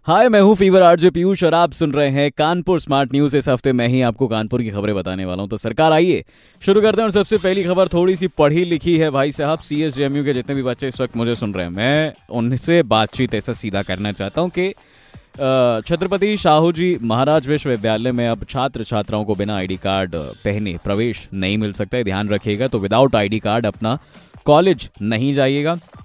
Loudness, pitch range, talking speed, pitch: -17 LUFS, 110-160 Hz, 205 wpm, 130 Hz